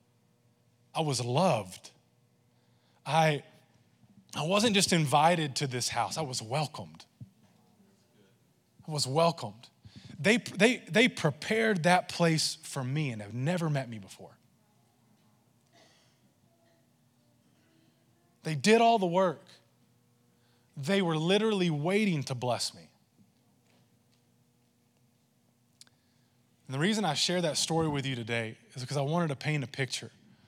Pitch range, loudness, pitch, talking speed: 120-175 Hz, -29 LUFS, 150 Hz, 120 wpm